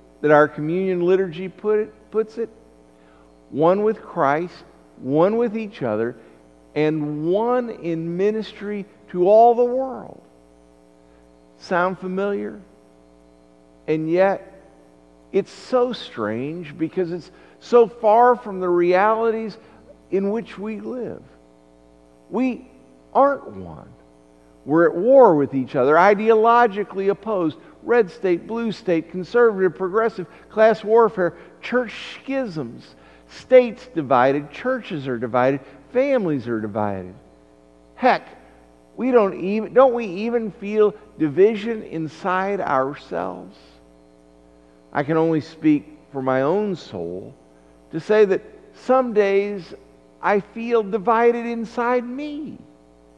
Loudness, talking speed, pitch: -20 LUFS, 110 wpm, 175 Hz